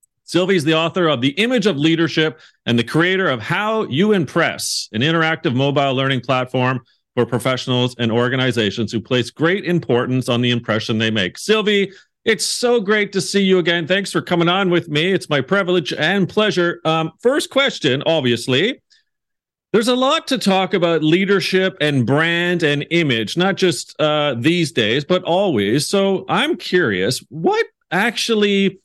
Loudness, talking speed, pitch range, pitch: -17 LUFS, 165 wpm, 130-195 Hz, 165 Hz